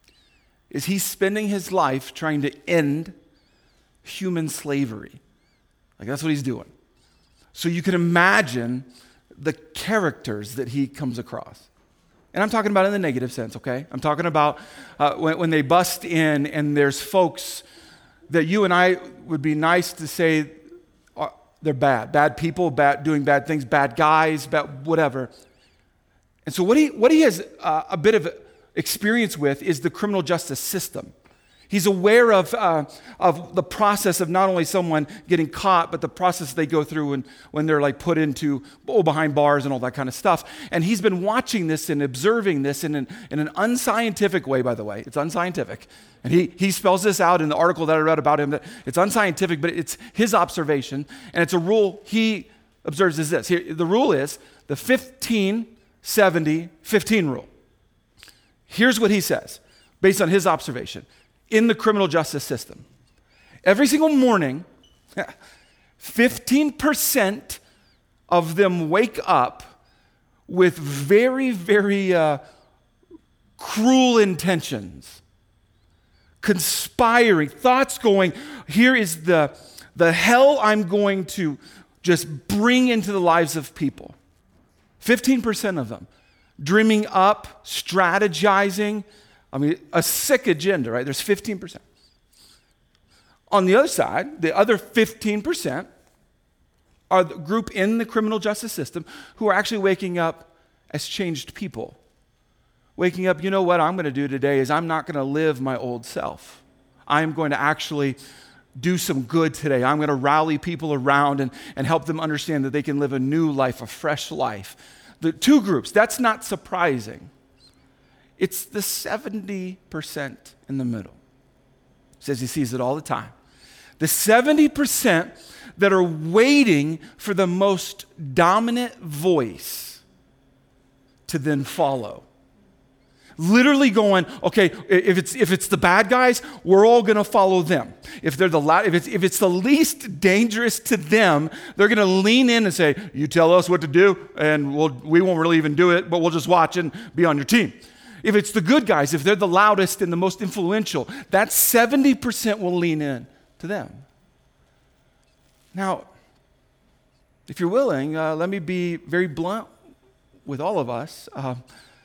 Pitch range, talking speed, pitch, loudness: 150-205 Hz, 160 wpm, 175 Hz, -20 LUFS